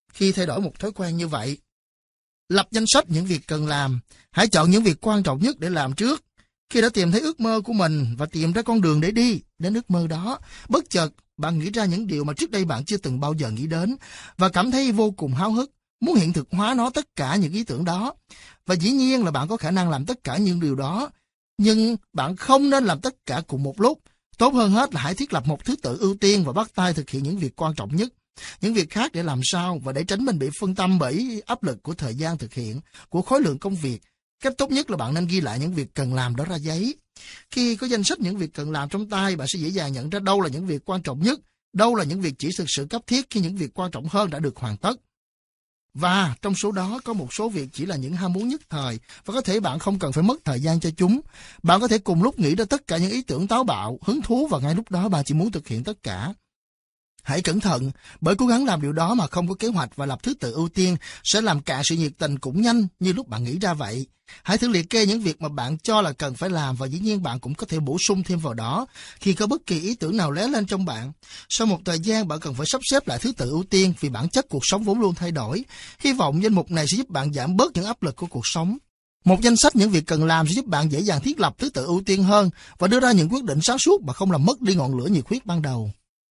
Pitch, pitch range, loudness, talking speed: 180 Hz, 150-215 Hz, -23 LUFS, 285 wpm